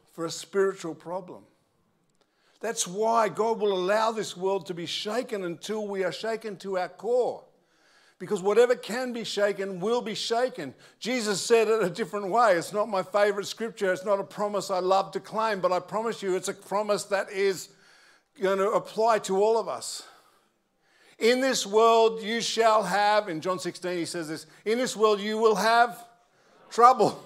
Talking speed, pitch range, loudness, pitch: 185 wpm, 185-225 Hz, -26 LUFS, 205 Hz